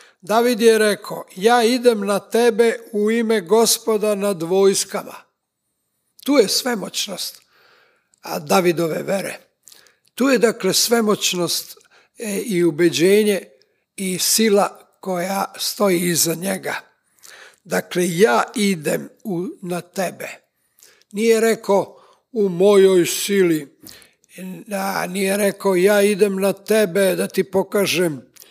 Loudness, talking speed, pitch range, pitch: -18 LUFS, 105 wpm, 185-220 Hz, 200 Hz